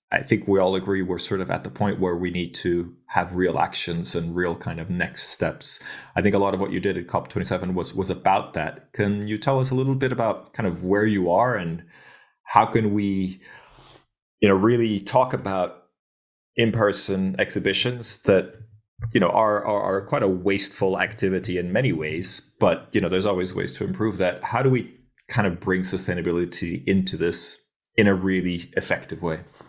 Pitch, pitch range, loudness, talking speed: 95 Hz, 90-105 Hz, -23 LUFS, 205 wpm